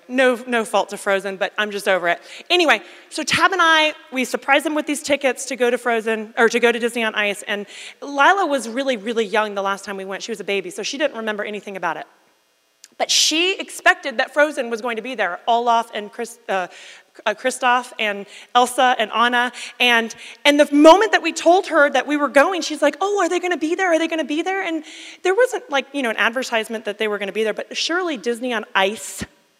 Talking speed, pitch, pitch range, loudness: 245 wpm, 240 Hz, 210-295 Hz, -19 LUFS